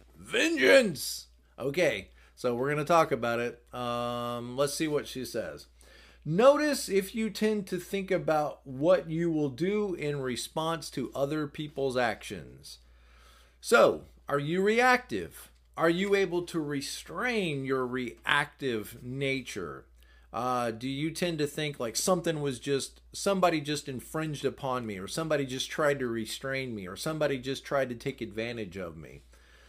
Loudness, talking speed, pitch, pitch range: -30 LUFS, 150 wpm, 140 Hz, 120-165 Hz